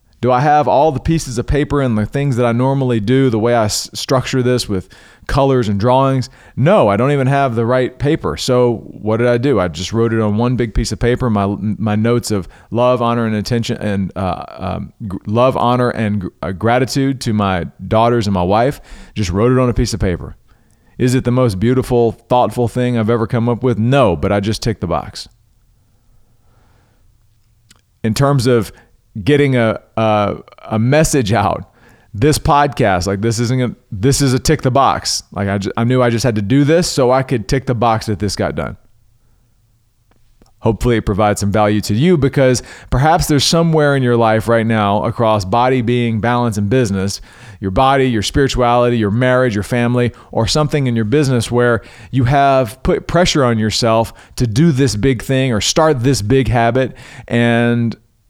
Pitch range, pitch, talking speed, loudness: 105-130 Hz, 120 Hz, 200 wpm, -15 LUFS